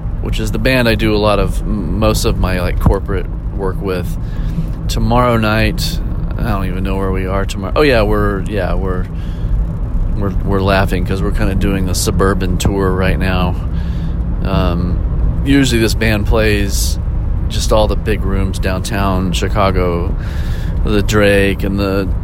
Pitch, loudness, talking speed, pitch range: 95 Hz, -16 LUFS, 160 wpm, 90-105 Hz